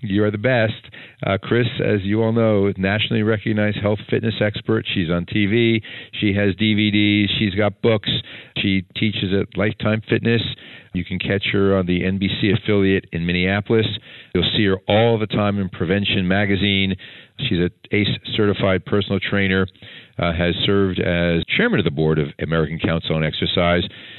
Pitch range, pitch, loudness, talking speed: 95-110 Hz, 100 Hz, -19 LUFS, 165 wpm